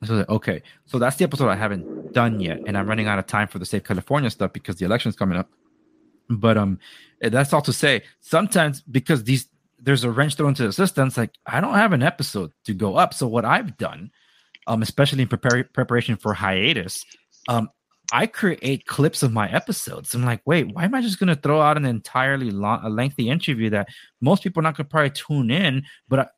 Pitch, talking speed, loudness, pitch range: 125 Hz, 220 wpm, -22 LUFS, 110-150 Hz